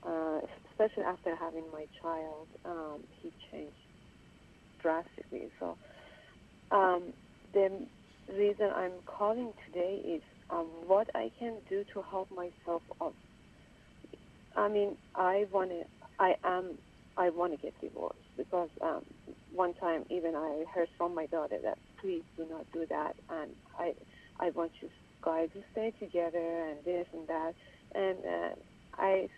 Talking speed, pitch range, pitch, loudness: 145 wpm, 165-195 Hz, 175 Hz, -36 LUFS